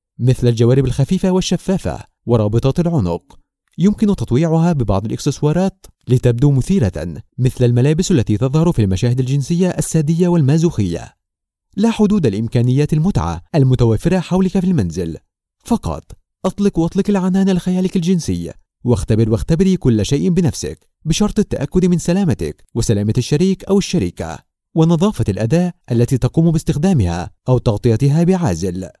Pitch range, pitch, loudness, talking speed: 115-180 Hz, 140 Hz, -16 LUFS, 115 wpm